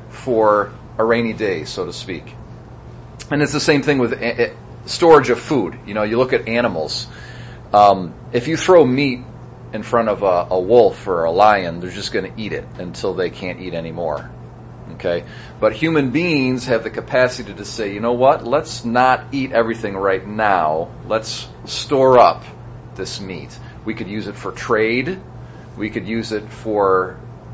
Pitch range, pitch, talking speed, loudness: 105-130 Hz, 120 Hz, 175 wpm, -18 LUFS